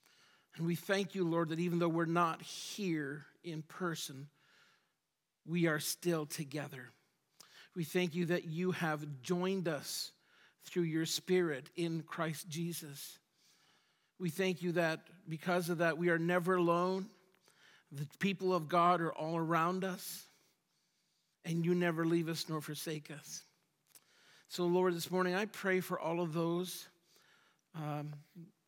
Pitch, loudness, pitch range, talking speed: 170 Hz, -36 LUFS, 160-180 Hz, 145 wpm